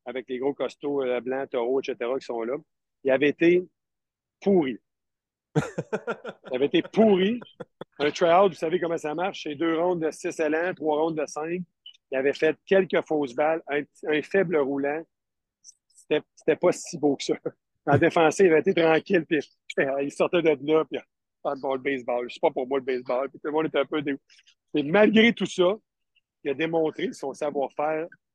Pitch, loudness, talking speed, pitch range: 155 Hz, -25 LUFS, 200 wpm, 140-175 Hz